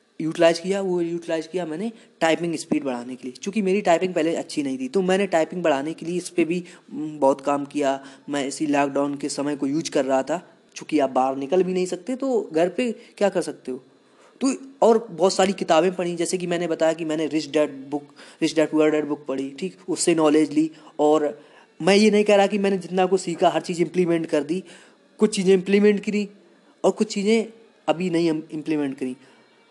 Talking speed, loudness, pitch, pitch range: 215 wpm, -23 LUFS, 170 Hz, 150-195 Hz